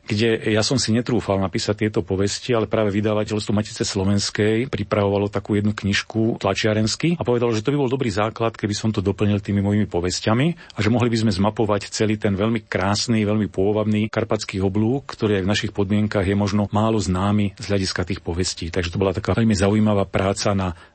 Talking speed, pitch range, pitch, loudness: 195 wpm, 100-110 Hz, 105 Hz, -21 LUFS